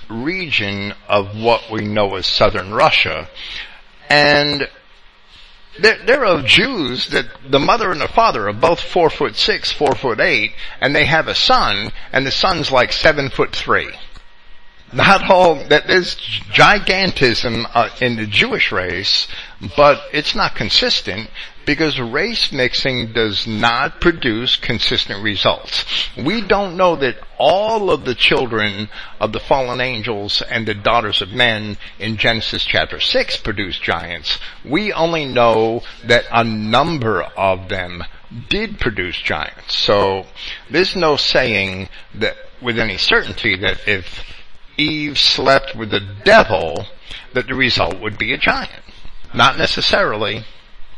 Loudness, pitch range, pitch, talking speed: -15 LUFS, 105-145 Hz, 115 Hz, 140 wpm